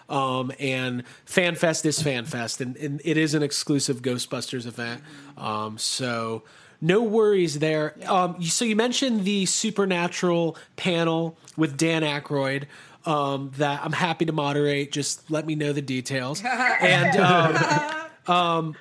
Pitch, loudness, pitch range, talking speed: 155 Hz, -24 LUFS, 140-175 Hz, 135 wpm